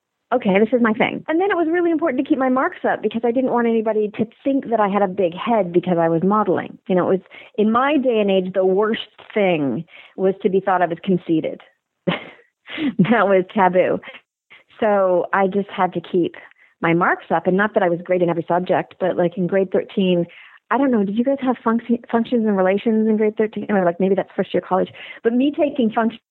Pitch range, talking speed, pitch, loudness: 185-240 Hz, 235 wpm, 210 Hz, -19 LUFS